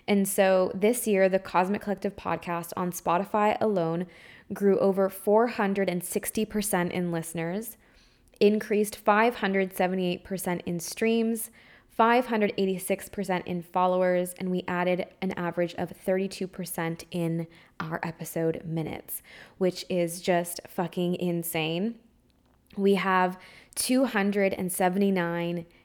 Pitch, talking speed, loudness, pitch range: 185 Hz, 95 wpm, -27 LUFS, 175-200 Hz